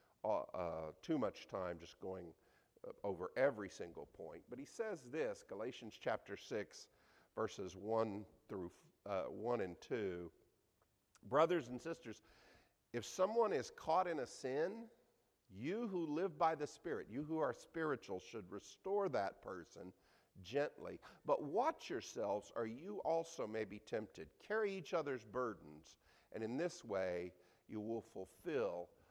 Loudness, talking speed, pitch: -43 LUFS, 145 wpm, 125 Hz